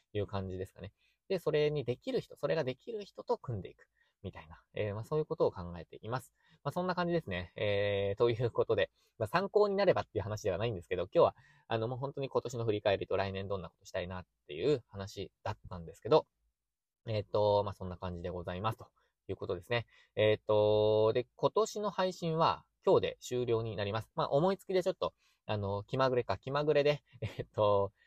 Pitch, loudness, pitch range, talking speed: 115 Hz, -34 LUFS, 100-155 Hz, 405 characters per minute